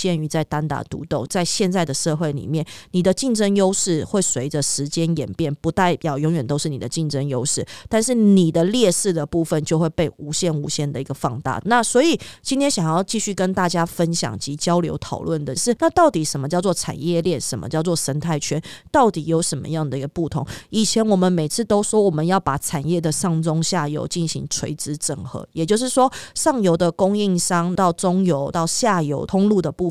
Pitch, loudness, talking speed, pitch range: 165 Hz, -20 LUFS, 315 characters per minute, 150-185 Hz